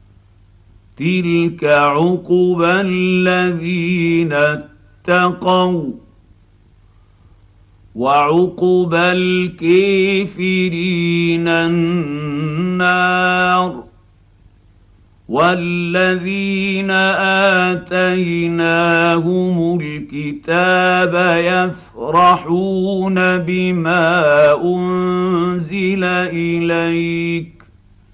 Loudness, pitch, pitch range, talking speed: -15 LUFS, 175 Hz, 150-180 Hz, 30 wpm